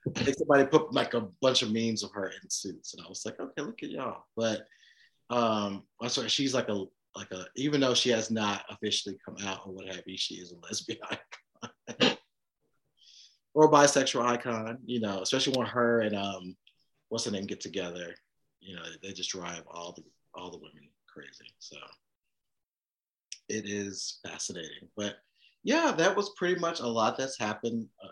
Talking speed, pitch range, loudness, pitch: 190 wpm, 95-125 Hz, -30 LUFS, 110 Hz